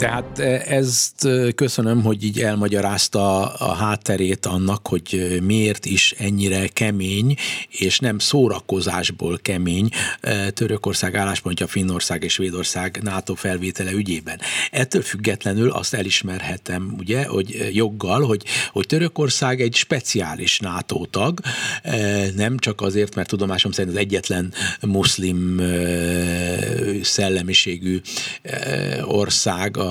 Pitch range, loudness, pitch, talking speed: 95-110 Hz, -20 LUFS, 100 Hz, 115 wpm